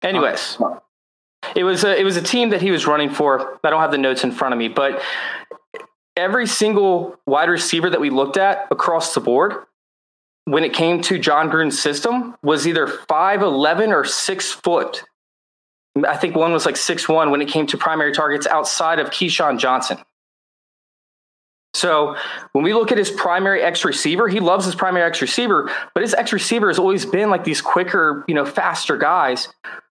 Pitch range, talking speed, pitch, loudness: 150-195 Hz, 190 wpm, 175 Hz, -18 LUFS